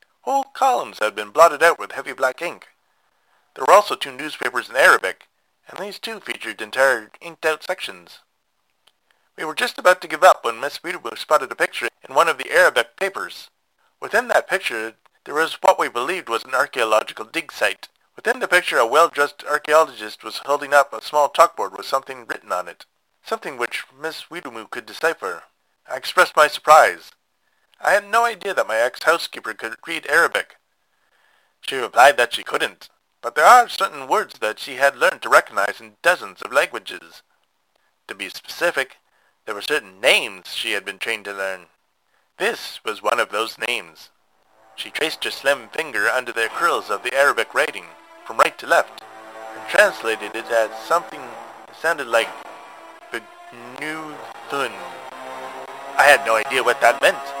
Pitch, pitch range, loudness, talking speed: 145 Hz, 110-185 Hz, -19 LUFS, 170 wpm